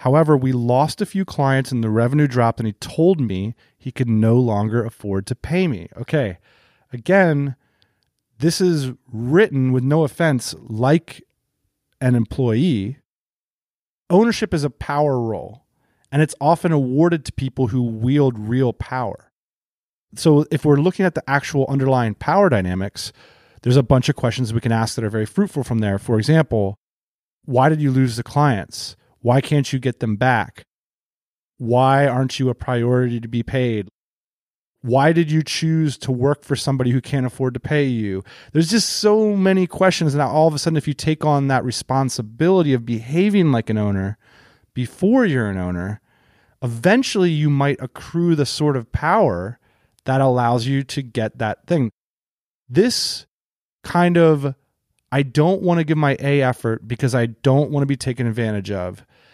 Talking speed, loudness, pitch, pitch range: 170 wpm, -19 LUFS, 130 Hz, 115-150 Hz